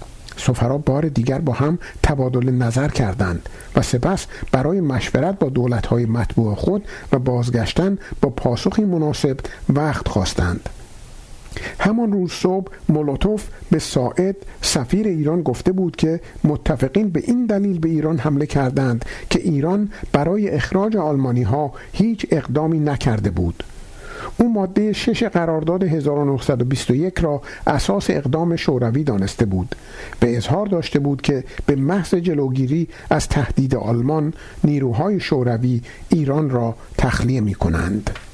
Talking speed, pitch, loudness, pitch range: 125 wpm, 145 Hz, -20 LUFS, 125-180 Hz